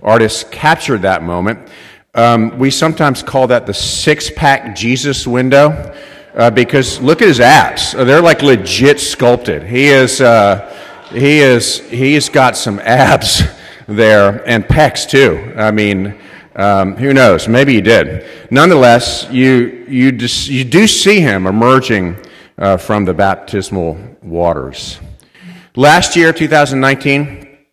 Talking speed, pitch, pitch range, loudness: 130 wpm, 125 Hz, 105-140 Hz, -10 LUFS